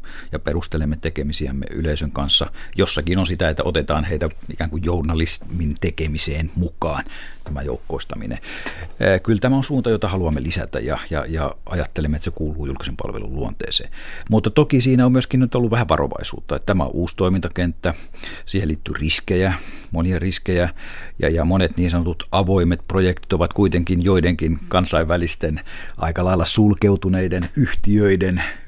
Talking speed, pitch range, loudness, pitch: 145 wpm, 80-95 Hz, -20 LUFS, 85 Hz